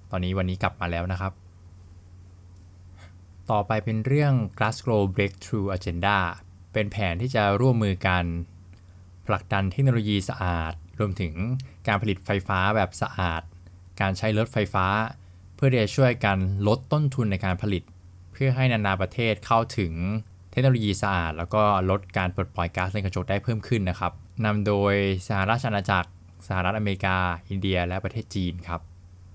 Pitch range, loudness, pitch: 90-110 Hz, -26 LUFS, 95 Hz